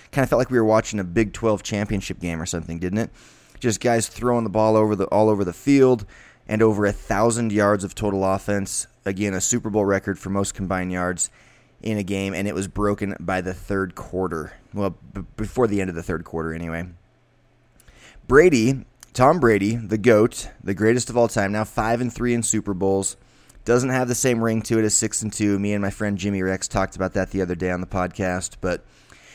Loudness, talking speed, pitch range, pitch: -22 LUFS, 225 wpm, 95-110 Hz, 100 Hz